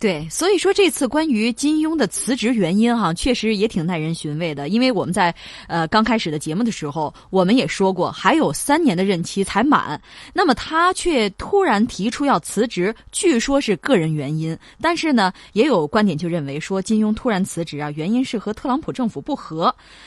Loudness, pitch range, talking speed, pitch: -19 LUFS, 175-255 Hz, 305 characters per minute, 215 Hz